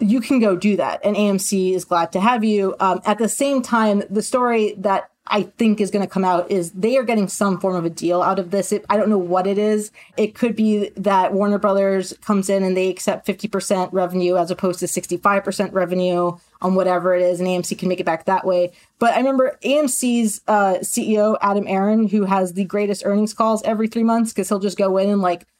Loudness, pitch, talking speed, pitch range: -19 LUFS, 200 Hz, 235 wpm, 185-215 Hz